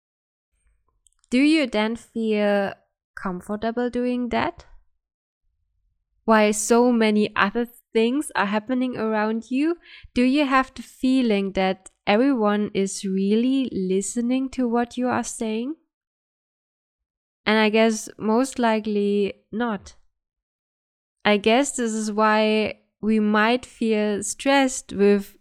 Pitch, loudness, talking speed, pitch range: 220 Hz, -22 LUFS, 110 wpm, 200-245 Hz